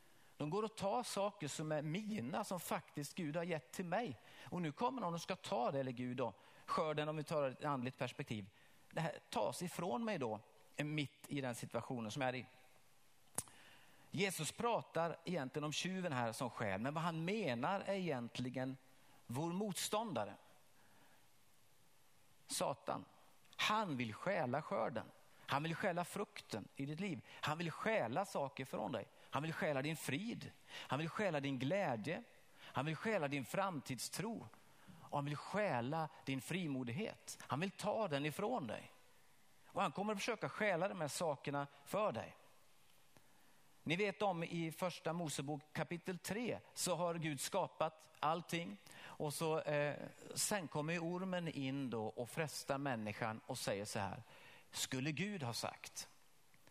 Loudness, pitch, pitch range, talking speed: -42 LUFS, 155 Hz, 135-185 Hz, 160 wpm